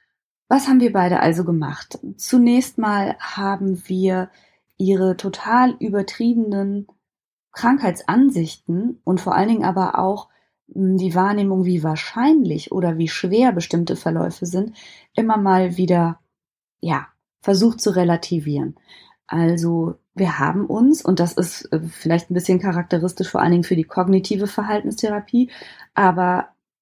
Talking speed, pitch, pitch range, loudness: 125 wpm, 185 Hz, 175-210 Hz, -19 LUFS